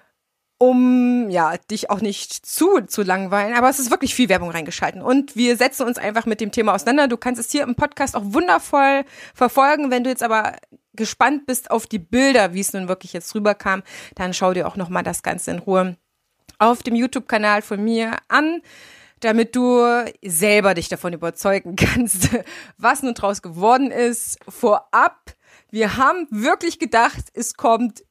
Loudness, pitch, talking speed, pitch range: -19 LUFS, 230 Hz, 180 wpm, 205-255 Hz